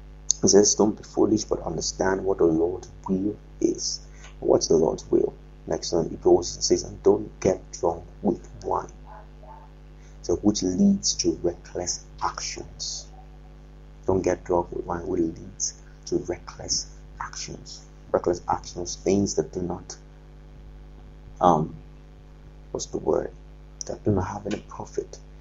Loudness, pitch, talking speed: -25 LUFS, 340 Hz, 140 wpm